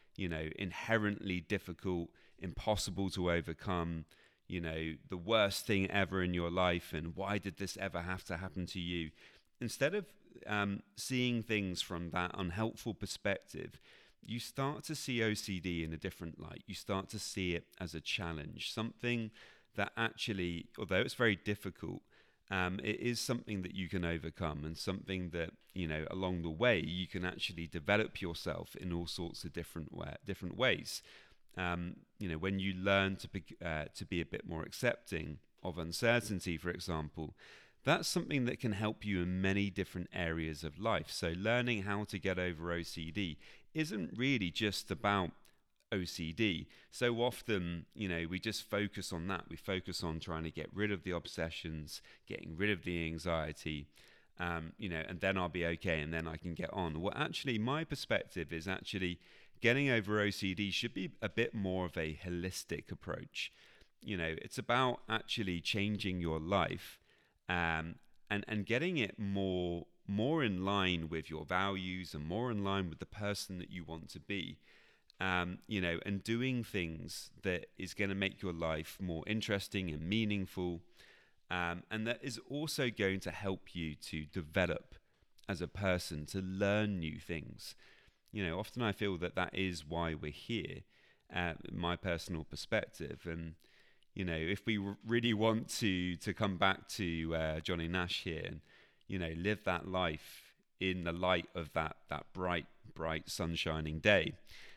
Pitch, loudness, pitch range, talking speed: 95 Hz, -38 LUFS, 85-105 Hz, 170 wpm